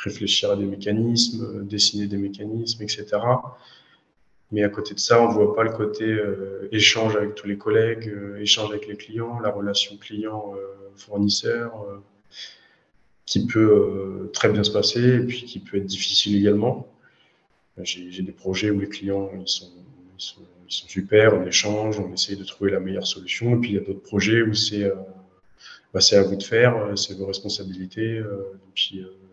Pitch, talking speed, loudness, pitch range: 105 Hz, 195 wpm, -22 LUFS, 100-110 Hz